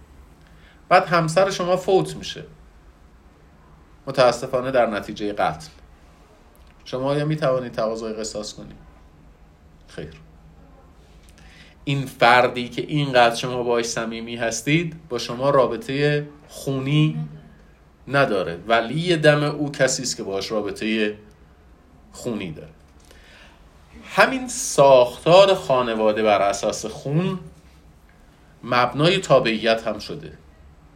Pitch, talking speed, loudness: 110 Hz, 95 wpm, -20 LUFS